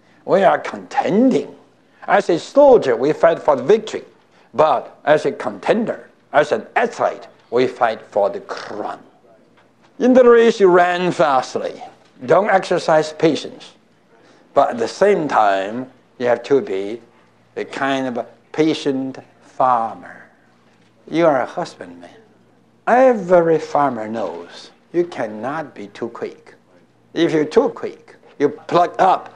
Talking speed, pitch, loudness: 135 wpm, 170 Hz, -17 LUFS